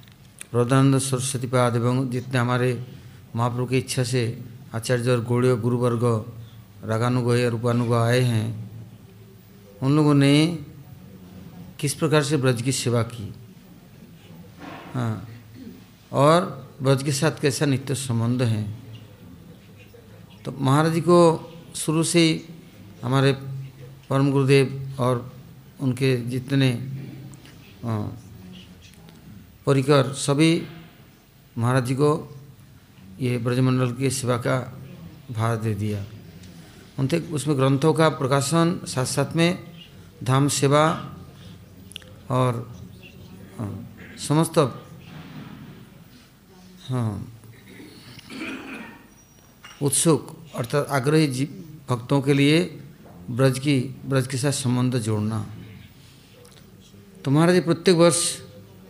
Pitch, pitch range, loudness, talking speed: 130 Hz, 120-145 Hz, -22 LUFS, 100 wpm